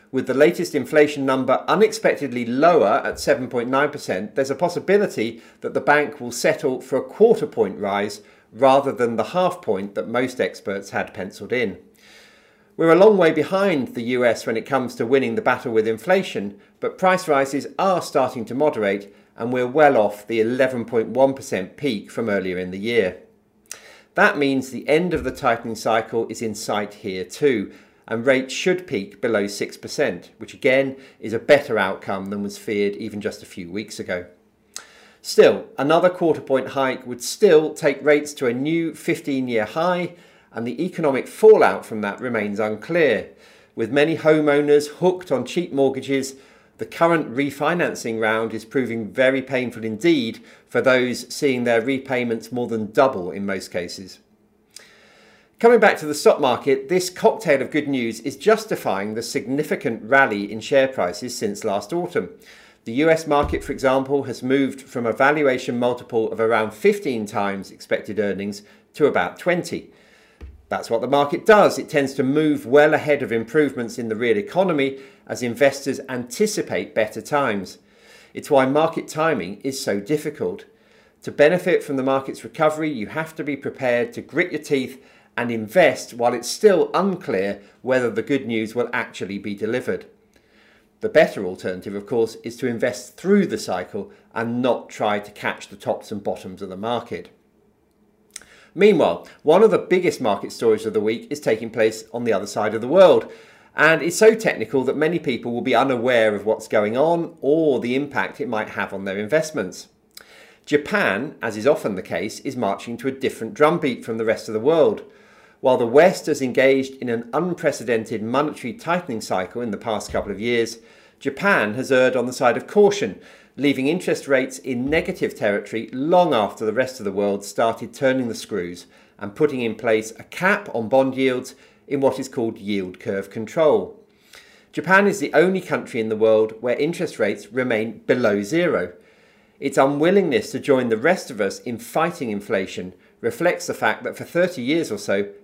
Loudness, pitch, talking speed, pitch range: -21 LUFS, 130 Hz, 175 wpm, 110-150 Hz